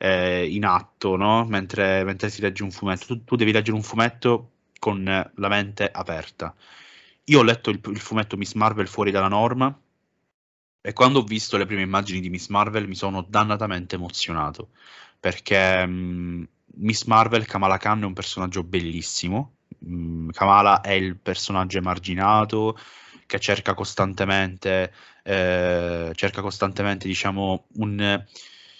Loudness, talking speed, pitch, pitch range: -22 LUFS, 140 wpm, 100 Hz, 95-105 Hz